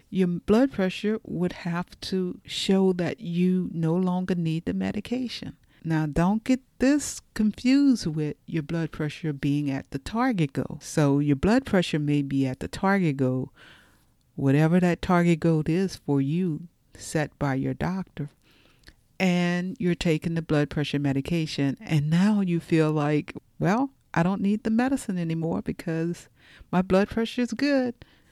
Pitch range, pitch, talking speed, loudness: 150-195 Hz, 170 Hz, 155 wpm, -26 LUFS